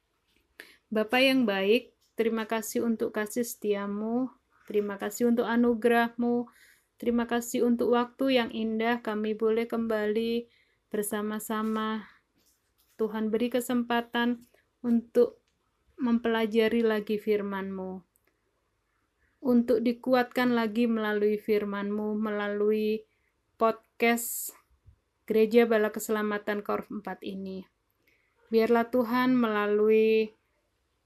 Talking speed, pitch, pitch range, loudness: 85 wpm, 225 Hz, 215-240 Hz, -28 LUFS